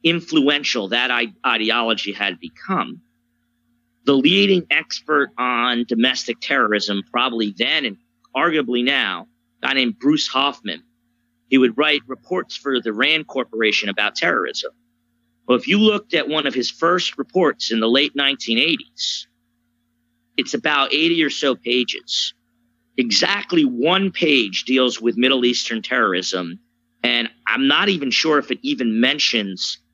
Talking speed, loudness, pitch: 135 wpm, -18 LUFS, 120 Hz